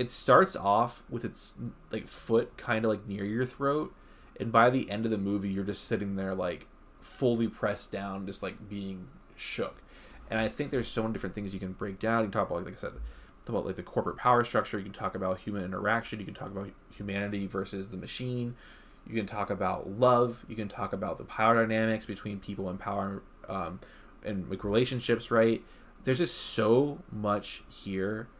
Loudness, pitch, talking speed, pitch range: -31 LUFS, 105 Hz, 205 wpm, 100-115 Hz